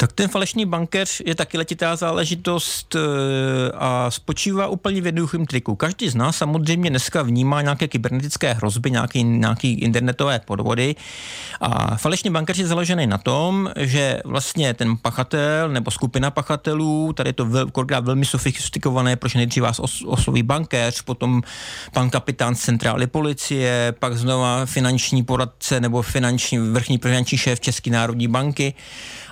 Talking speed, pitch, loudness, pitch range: 145 wpm, 130 Hz, -20 LUFS, 125-155 Hz